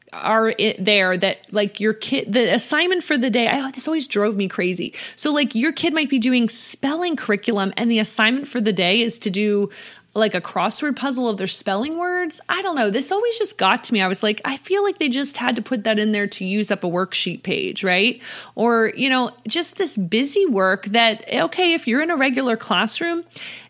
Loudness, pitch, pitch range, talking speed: -20 LUFS, 230 Hz, 210-280 Hz, 230 wpm